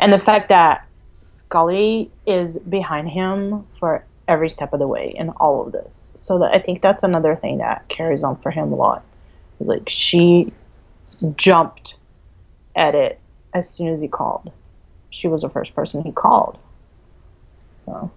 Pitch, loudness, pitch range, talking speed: 180 Hz, -18 LUFS, 165-200 Hz, 165 wpm